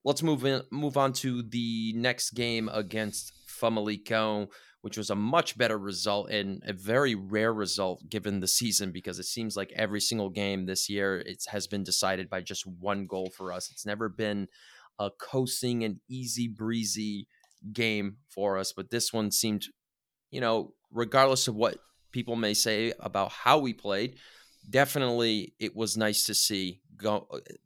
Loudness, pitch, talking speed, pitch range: -29 LUFS, 110 Hz, 170 wpm, 100-120 Hz